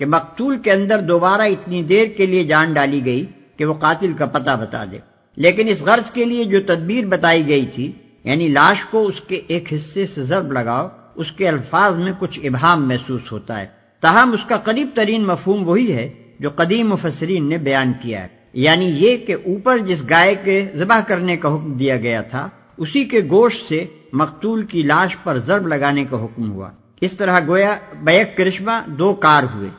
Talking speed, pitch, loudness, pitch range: 195 wpm, 170 Hz, -16 LUFS, 140-195 Hz